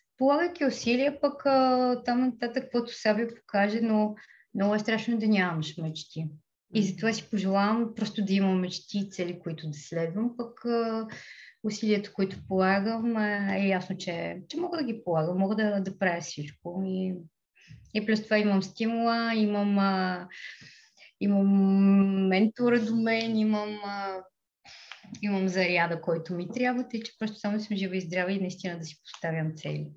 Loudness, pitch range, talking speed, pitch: -28 LUFS, 185-225 Hz, 160 wpm, 205 Hz